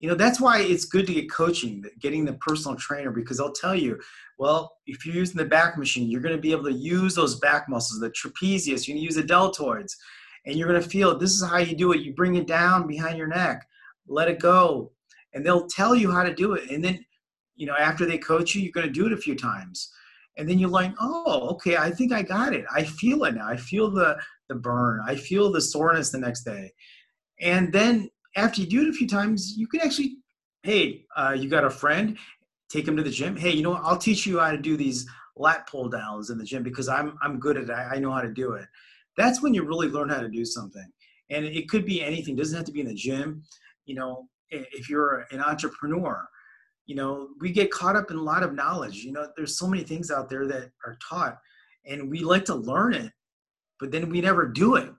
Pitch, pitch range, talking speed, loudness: 160 Hz, 140-185 Hz, 250 wpm, -25 LUFS